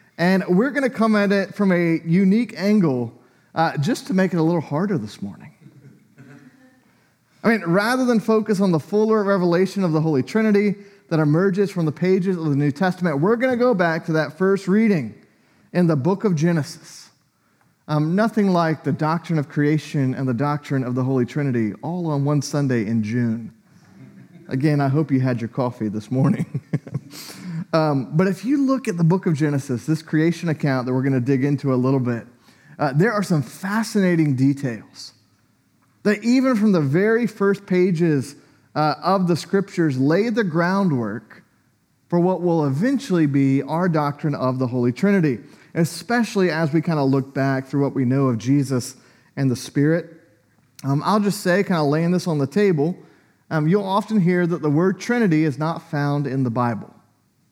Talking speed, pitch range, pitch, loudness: 190 wpm, 140-195 Hz, 160 Hz, -20 LUFS